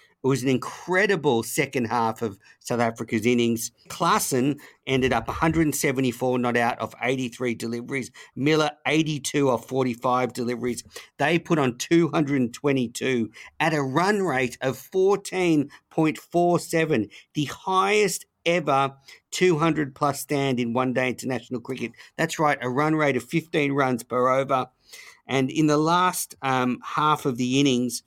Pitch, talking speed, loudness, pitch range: 135 Hz, 135 wpm, -24 LUFS, 125-155 Hz